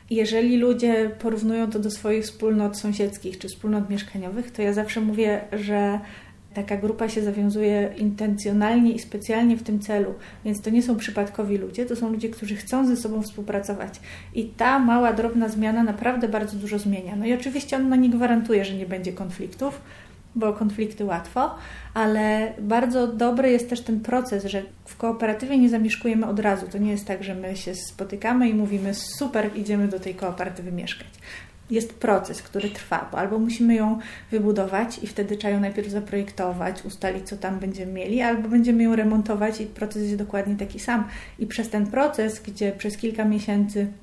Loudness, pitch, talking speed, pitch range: -24 LUFS, 215 Hz, 180 wpm, 205-230 Hz